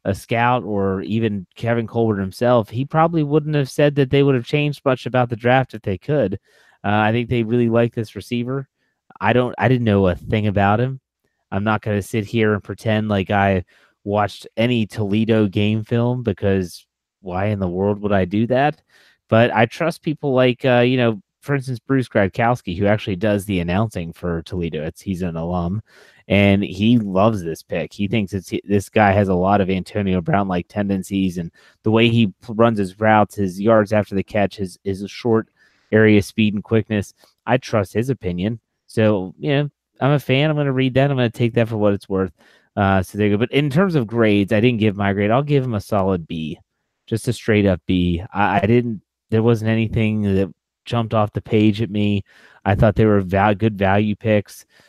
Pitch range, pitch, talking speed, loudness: 100-120 Hz, 110 Hz, 215 wpm, -19 LUFS